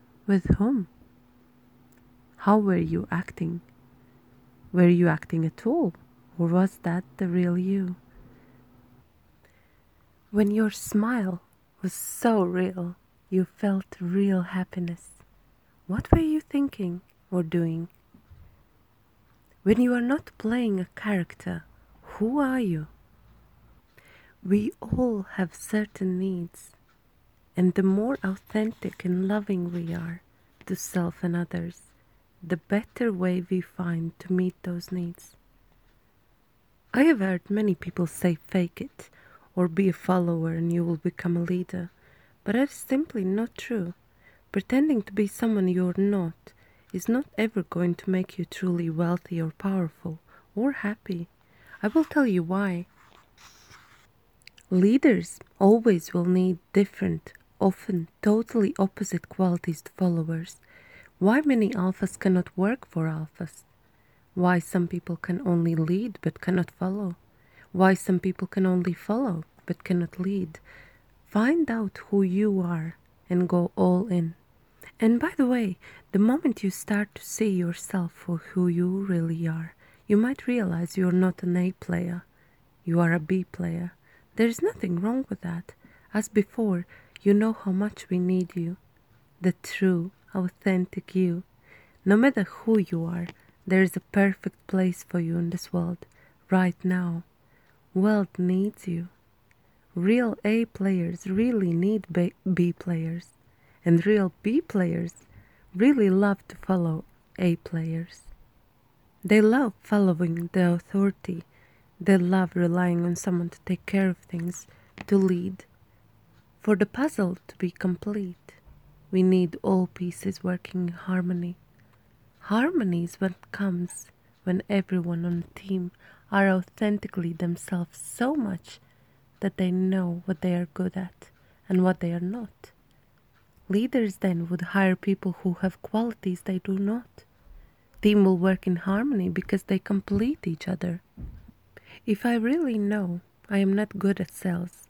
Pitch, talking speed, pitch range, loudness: 185 Hz, 140 wpm, 170-200 Hz, -26 LUFS